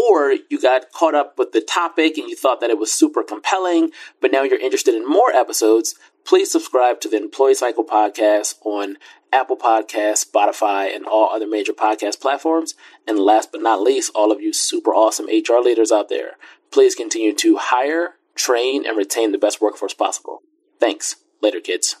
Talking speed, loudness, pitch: 185 wpm, -18 LUFS, 315 Hz